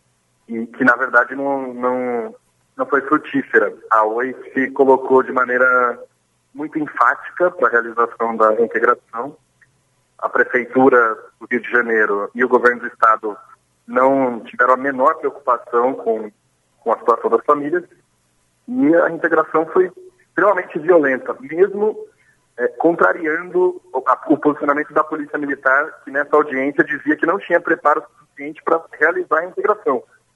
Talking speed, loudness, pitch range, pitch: 145 wpm, -17 LUFS, 125-205 Hz, 145 Hz